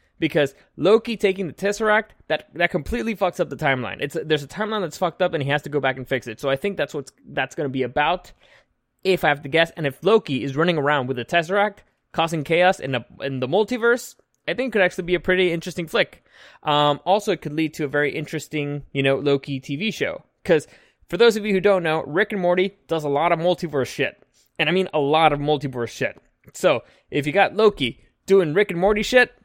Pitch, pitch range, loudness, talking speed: 165 Hz, 145-195 Hz, -22 LUFS, 240 wpm